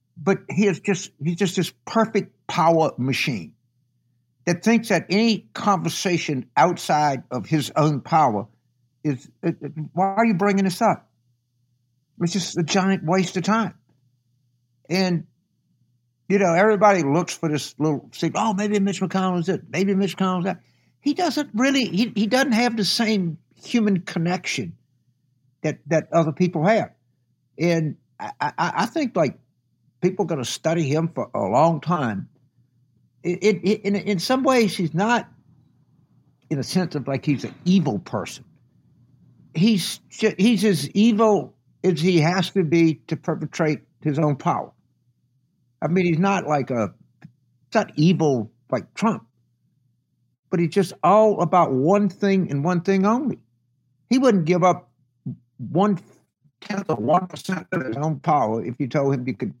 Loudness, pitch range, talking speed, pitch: -22 LUFS, 135-195 Hz, 160 wpm, 170 Hz